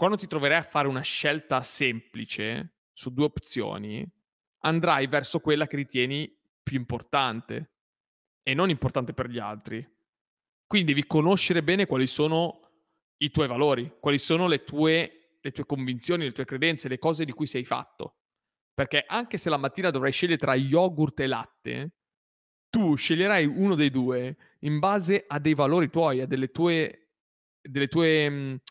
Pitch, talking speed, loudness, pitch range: 145 Hz, 160 wpm, -26 LUFS, 130-165 Hz